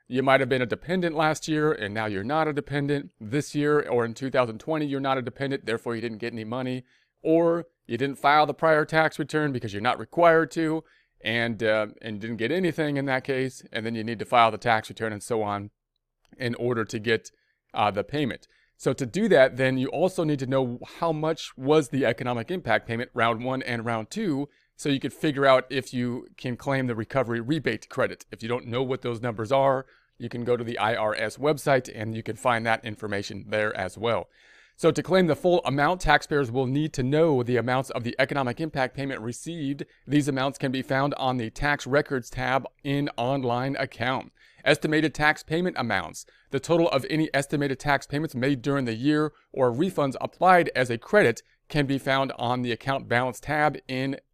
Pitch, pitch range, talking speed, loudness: 135 Hz, 120-150 Hz, 210 wpm, -26 LUFS